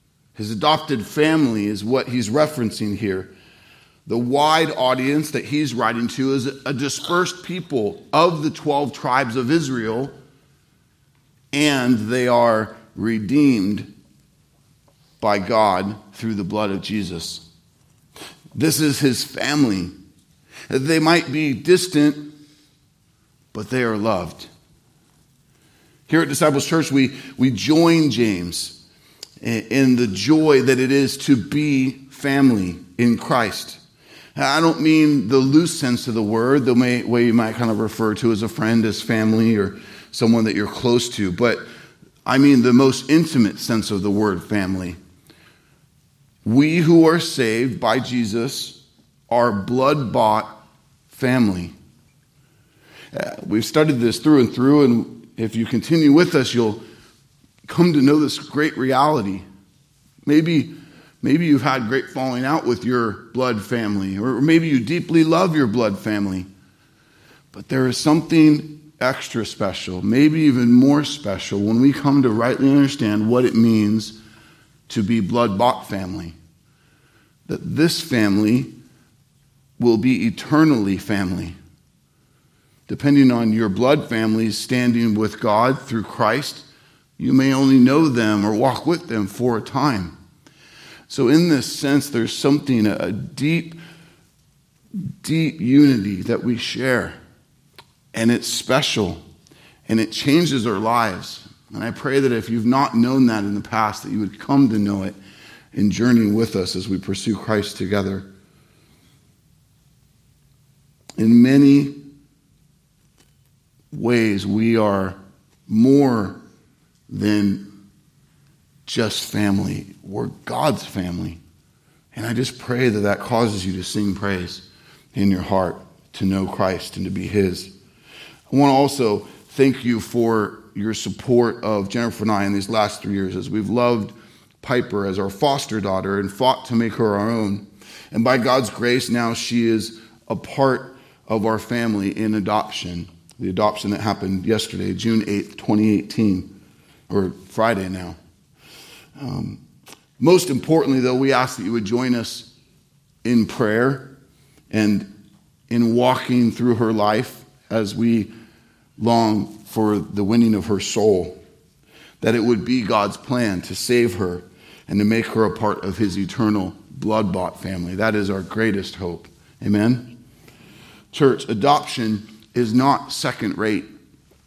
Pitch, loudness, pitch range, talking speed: 120 Hz, -19 LUFS, 105-140 Hz, 140 wpm